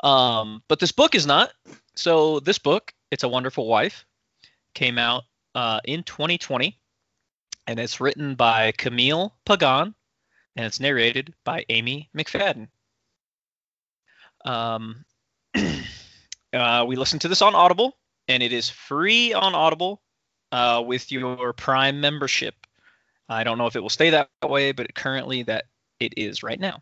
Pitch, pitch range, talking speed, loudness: 130 Hz, 120-155 Hz, 145 wpm, -22 LUFS